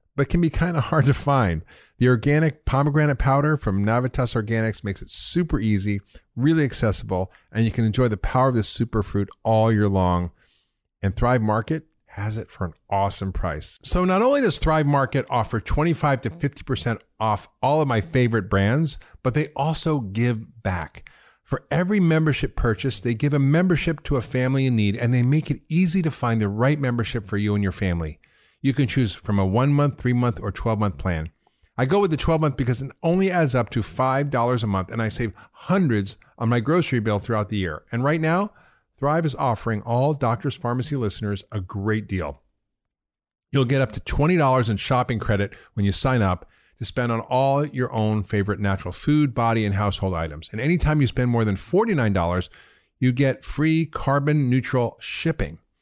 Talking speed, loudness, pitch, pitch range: 190 wpm, -22 LUFS, 120 Hz, 105-145 Hz